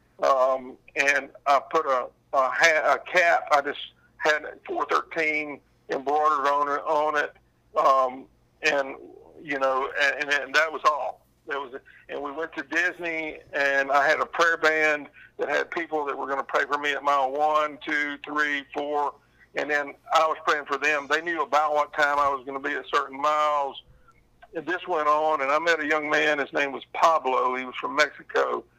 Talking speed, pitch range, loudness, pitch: 200 wpm, 140-155 Hz, -24 LUFS, 150 Hz